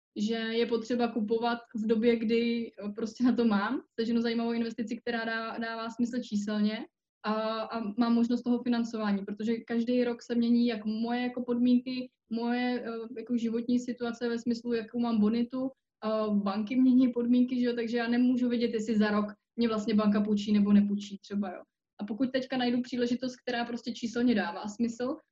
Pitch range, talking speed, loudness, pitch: 220-245 Hz, 175 wpm, -30 LUFS, 235 Hz